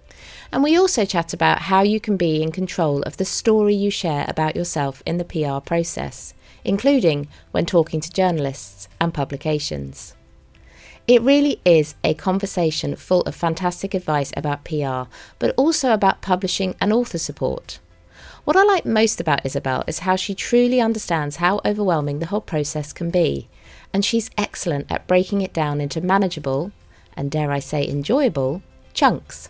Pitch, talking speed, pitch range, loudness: 170 Hz, 165 wpm, 145-200 Hz, -20 LUFS